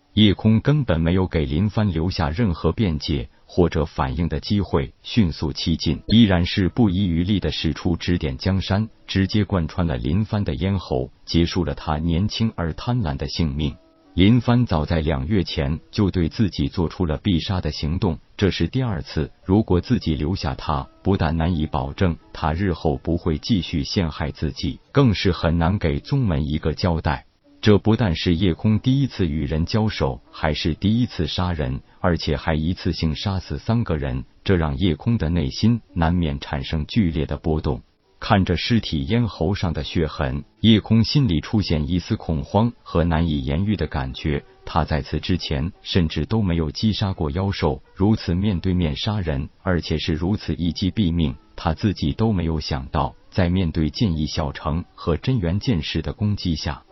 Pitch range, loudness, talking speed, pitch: 80-100 Hz, -22 LUFS, 265 characters per minute, 85 Hz